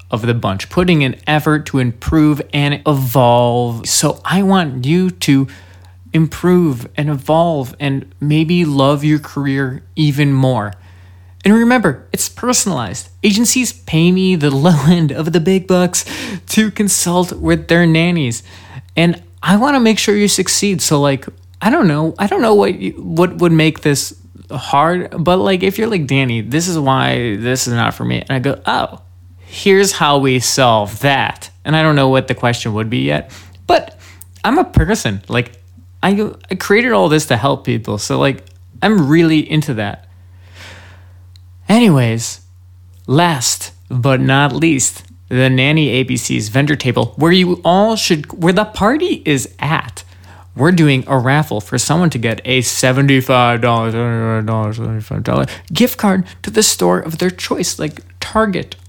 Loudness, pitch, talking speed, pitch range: -14 LUFS, 140 Hz, 160 wpm, 110-175 Hz